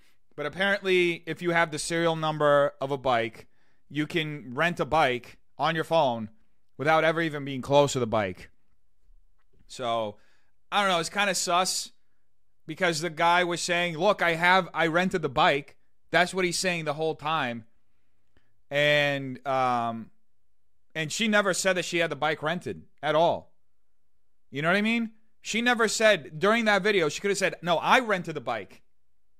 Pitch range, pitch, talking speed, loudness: 125-180 Hz, 160 Hz, 180 wpm, -26 LUFS